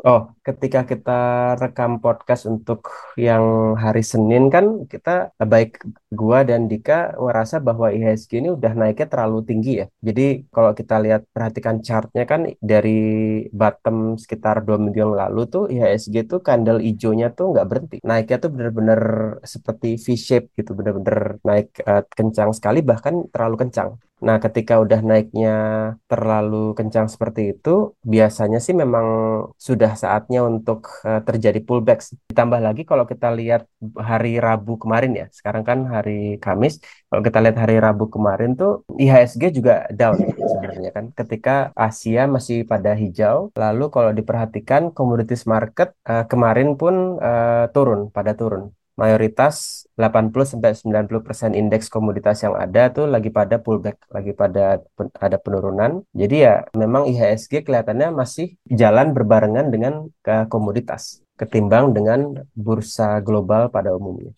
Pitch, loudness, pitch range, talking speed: 115 Hz, -18 LUFS, 110-125 Hz, 145 wpm